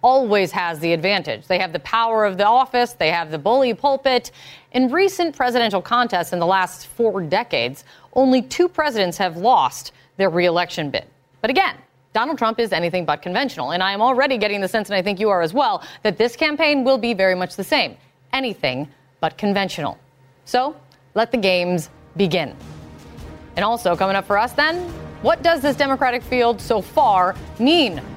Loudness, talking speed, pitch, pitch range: -19 LUFS, 185 wpm, 205 Hz, 175-250 Hz